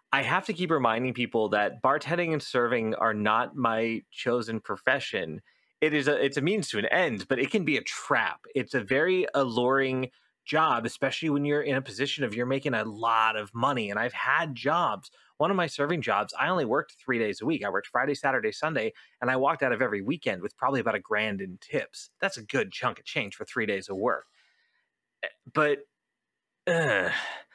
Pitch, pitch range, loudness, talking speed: 130 Hz, 115-150 Hz, -28 LUFS, 210 wpm